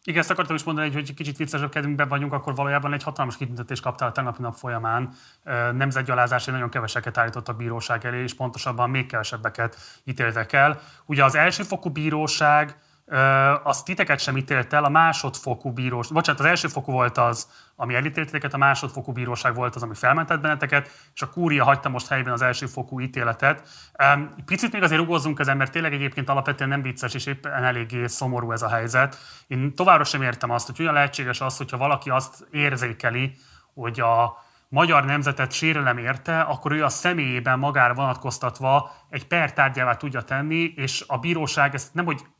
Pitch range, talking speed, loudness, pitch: 125-150 Hz, 175 wpm, -23 LUFS, 135 Hz